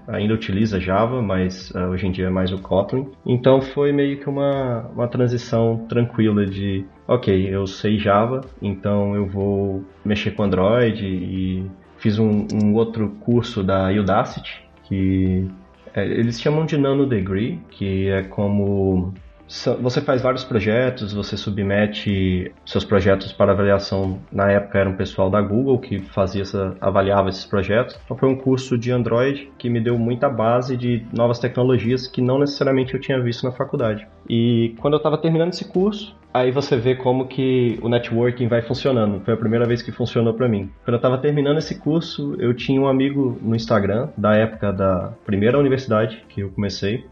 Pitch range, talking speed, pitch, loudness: 100-125 Hz, 175 wpm, 110 Hz, -20 LUFS